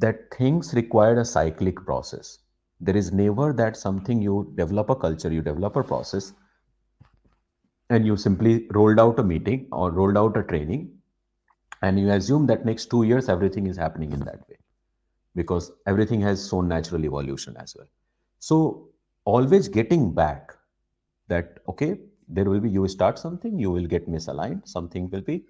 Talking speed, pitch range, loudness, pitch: 165 wpm, 90-115 Hz, -23 LUFS, 100 Hz